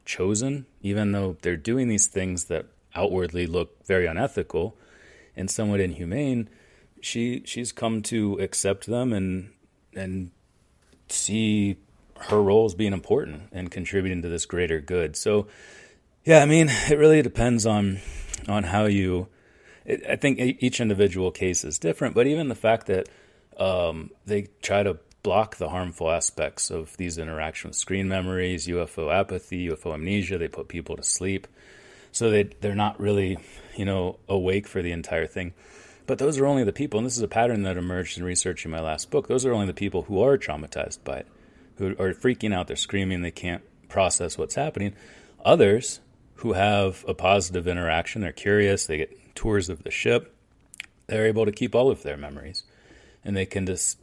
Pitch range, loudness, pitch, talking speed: 90-105 Hz, -25 LUFS, 100 Hz, 175 wpm